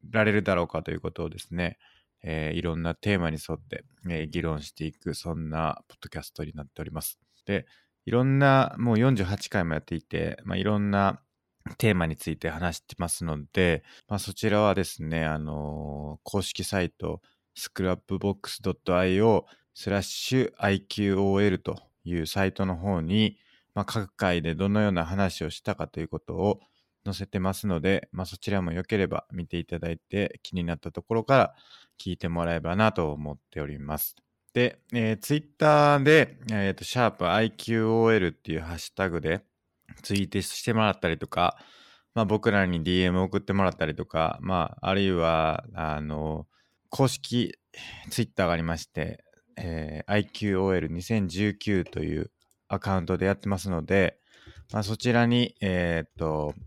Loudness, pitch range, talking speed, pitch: -27 LUFS, 80-105 Hz, 350 characters per minute, 95 Hz